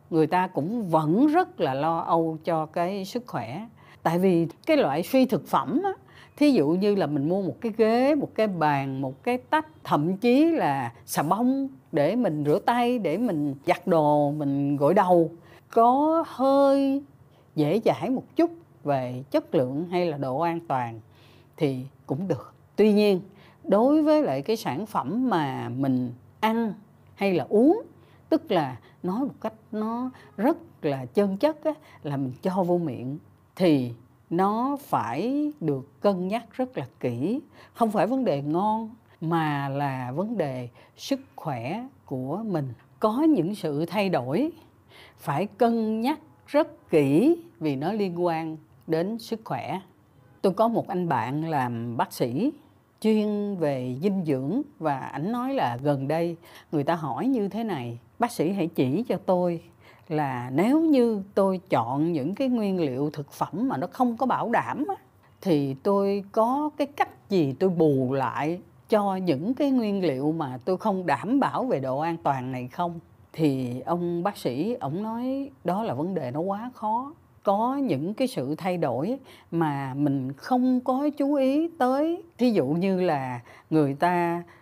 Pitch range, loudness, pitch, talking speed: 145-245 Hz, -26 LUFS, 180 Hz, 170 wpm